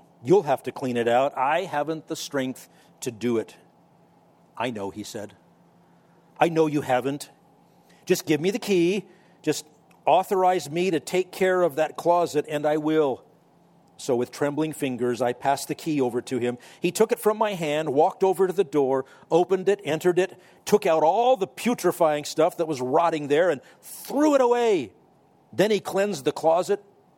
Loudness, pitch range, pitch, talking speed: -24 LUFS, 140-185 Hz, 160 Hz, 185 wpm